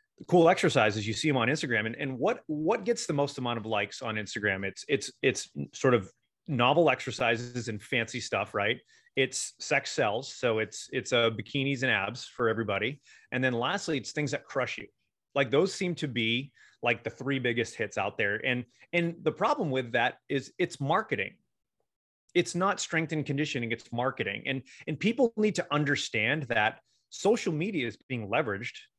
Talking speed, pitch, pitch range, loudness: 185 wpm, 135 Hz, 115-160 Hz, -29 LUFS